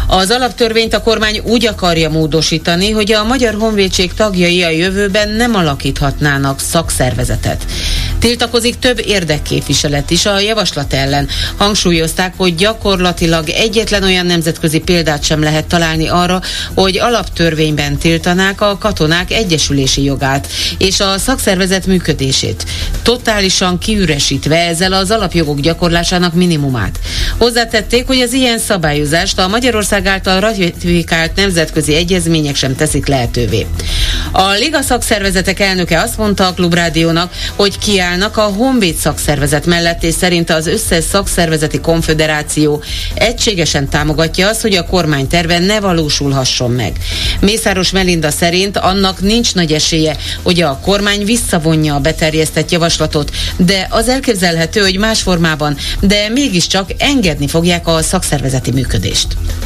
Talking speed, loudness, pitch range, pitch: 125 wpm, -12 LUFS, 150-200 Hz, 170 Hz